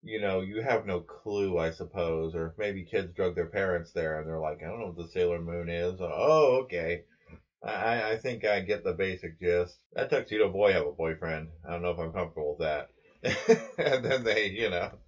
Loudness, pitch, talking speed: -30 LUFS, 100 Hz, 225 wpm